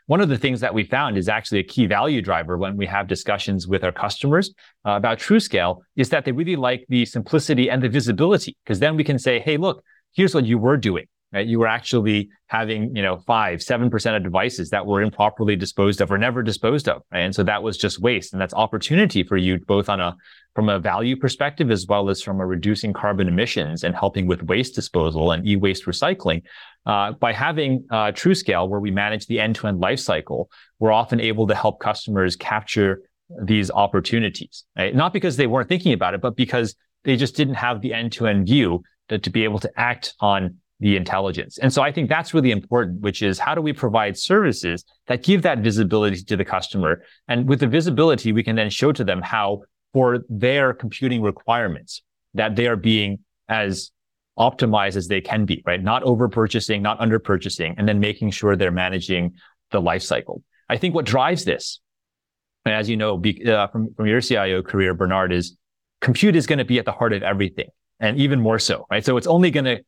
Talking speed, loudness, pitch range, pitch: 210 wpm, -21 LUFS, 100-125 Hz, 110 Hz